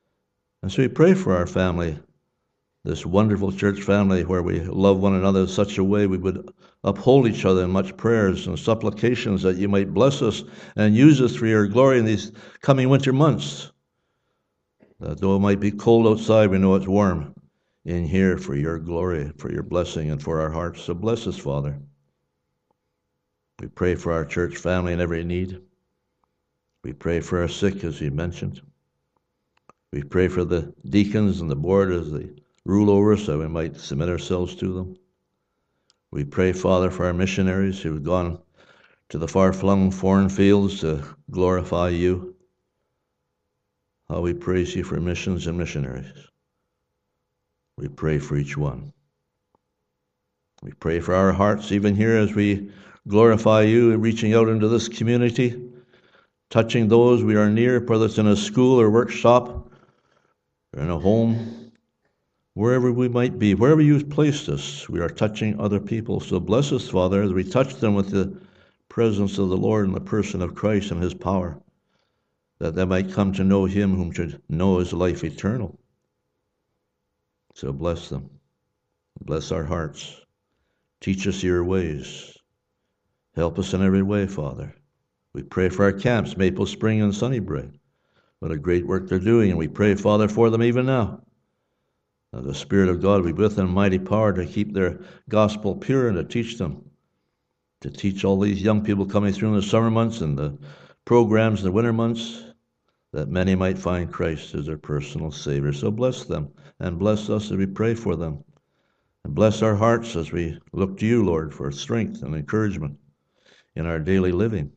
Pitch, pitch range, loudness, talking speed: 95 Hz, 85-110 Hz, -22 LUFS, 175 wpm